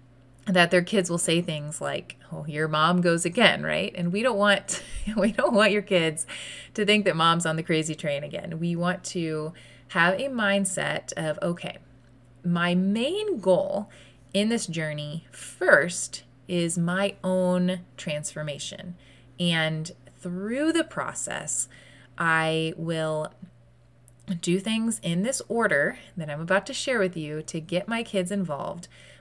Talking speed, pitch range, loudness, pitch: 150 wpm, 155-195 Hz, -25 LUFS, 175 Hz